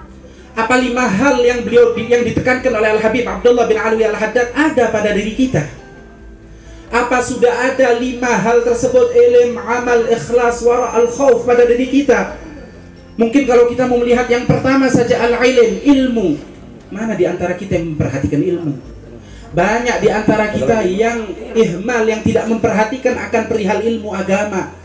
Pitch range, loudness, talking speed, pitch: 215-245 Hz, -14 LUFS, 155 wpm, 235 Hz